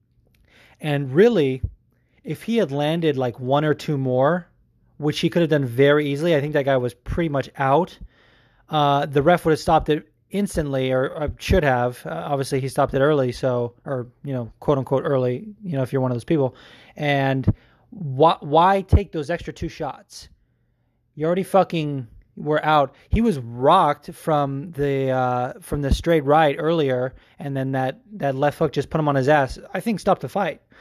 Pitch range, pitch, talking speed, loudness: 130-165 Hz, 145 Hz, 195 wpm, -21 LUFS